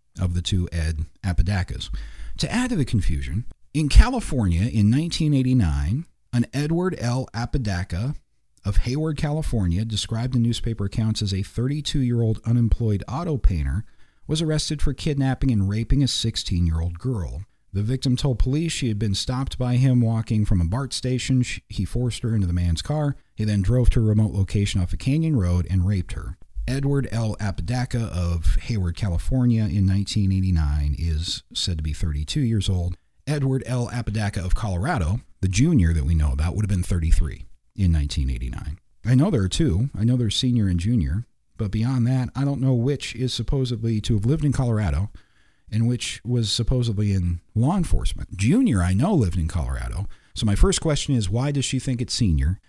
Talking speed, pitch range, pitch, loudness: 180 wpm, 90-125 Hz, 110 Hz, -23 LUFS